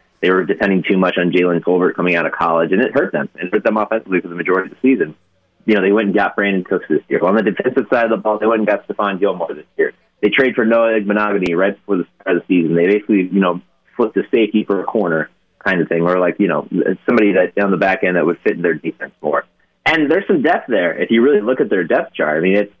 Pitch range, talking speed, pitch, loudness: 90-110 Hz, 290 wpm, 100 Hz, -16 LUFS